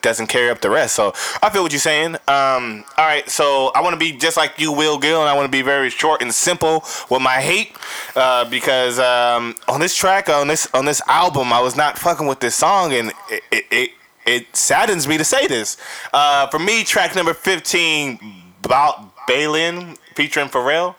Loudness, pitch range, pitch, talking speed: -16 LUFS, 130-165 Hz, 150 Hz, 215 wpm